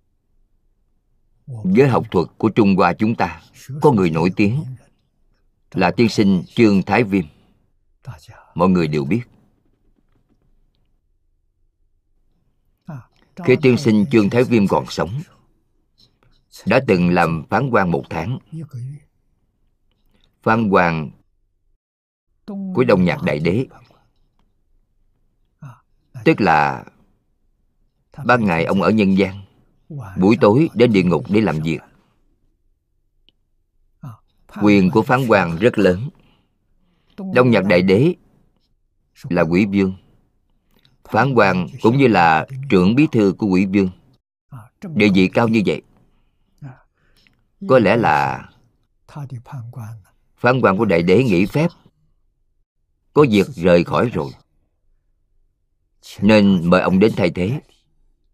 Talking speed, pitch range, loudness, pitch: 115 wpm, 85-120 Hz, -16 LUFS, 100 Hz